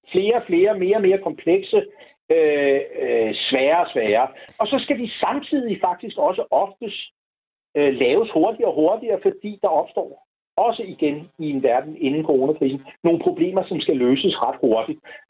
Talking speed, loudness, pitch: 165 wpm, -20 LUFS, 225 Hz